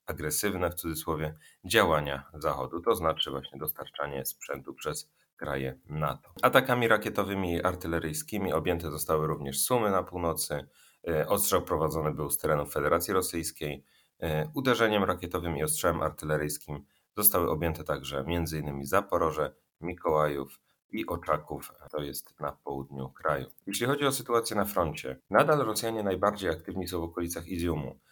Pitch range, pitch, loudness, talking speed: 75-95 Hz, 80 Hz, -30 LUFS, 135 wpm